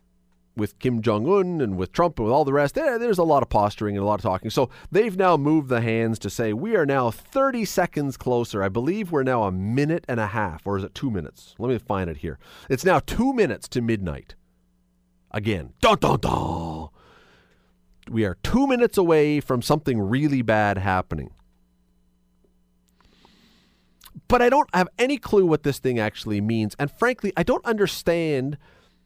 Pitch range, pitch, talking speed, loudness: 95-155 Hz, 115 Hz, 190 wpm, -23 LUFS